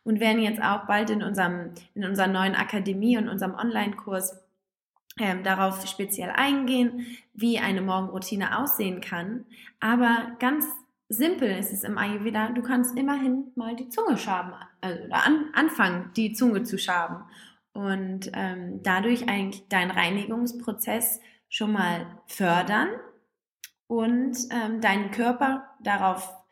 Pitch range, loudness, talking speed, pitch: 190-240 Hz, -26 LUFS, 135 wpm, 215 Hz